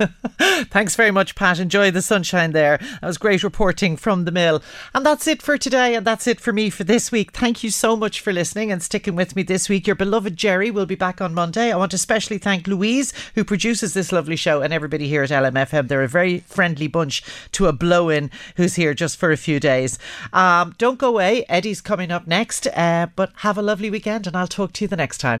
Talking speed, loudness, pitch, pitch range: 240 wpm, -19 LUFS, 195 Hz, 170-215 Hz